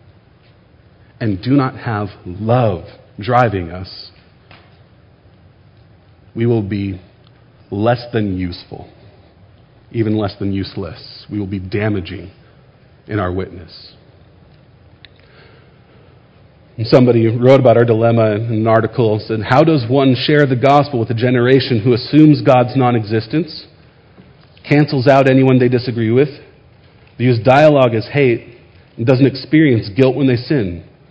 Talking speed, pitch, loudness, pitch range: 125 wpm, 120 Hz, -14 LUFS, 105-130 Hz